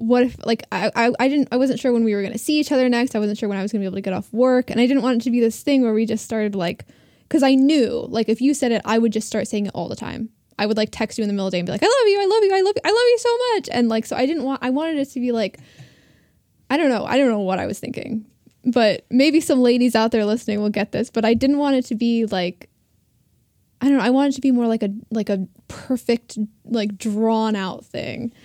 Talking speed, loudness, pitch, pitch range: 315 wpm, -20 LUFS, 235 Hz, 215-265 Hz